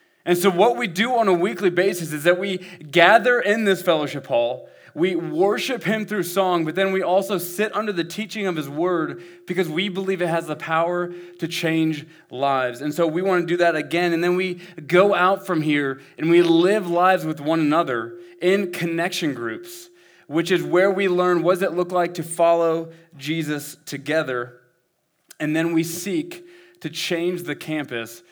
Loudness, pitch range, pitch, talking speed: -21 LUFS, 160-190 Hz, 175 Hz, 190 wpm